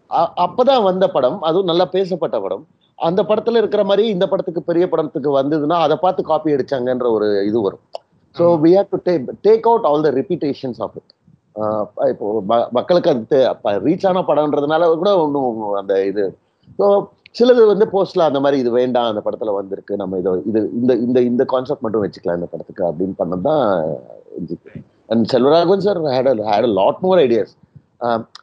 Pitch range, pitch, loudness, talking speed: 120-190 Hz, 155 Hz, -17 LUFS, 165 wpm